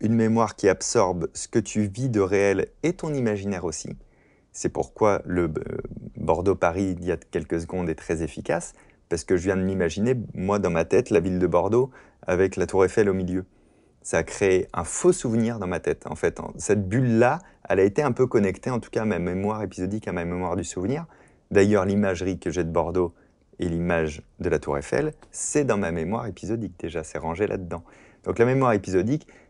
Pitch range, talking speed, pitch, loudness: 90-115 Hz, 210 wpm, 100 Hz, -25 LUFS